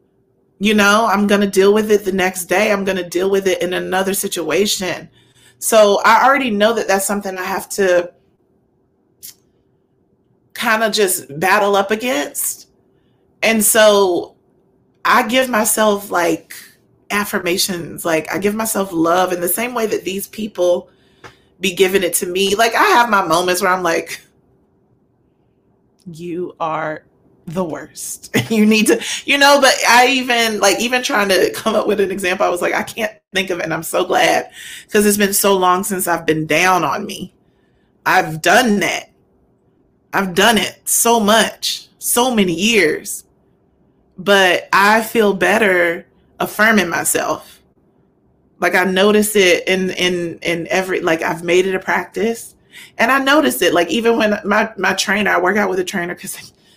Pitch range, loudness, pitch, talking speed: 180-215 Hz, -15 LUFS, 195 Hz, 170 wpm